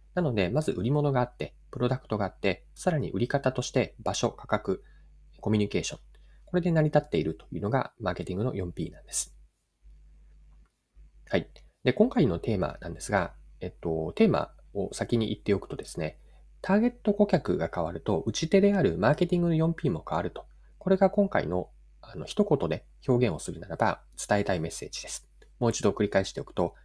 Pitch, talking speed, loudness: 120 Hz, 395 characters per minute, -29 LUFS